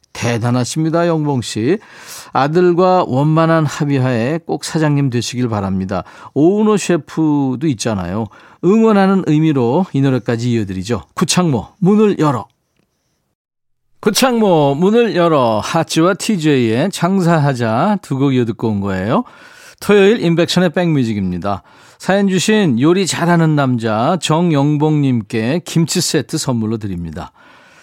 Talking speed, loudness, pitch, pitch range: 280 characters per minute, -15 LUFS, 155 Hz, 120-180 Hz